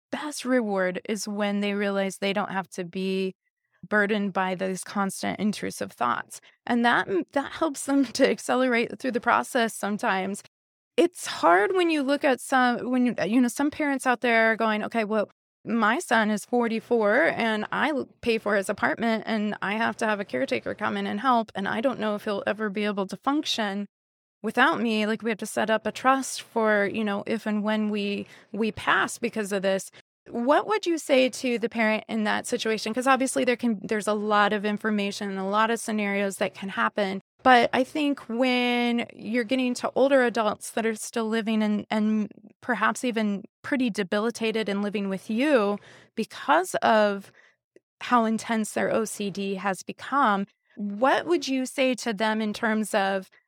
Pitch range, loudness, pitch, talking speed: 205-245 Hz, -25 LUFS, 220 Hz, 190 wpm